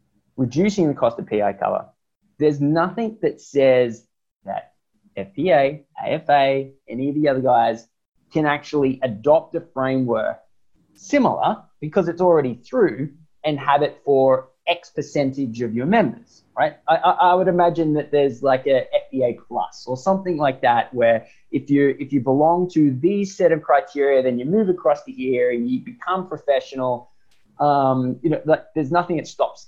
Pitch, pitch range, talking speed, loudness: 145 Hz, 130-165 Hz, 165 wpm, -20 LUFS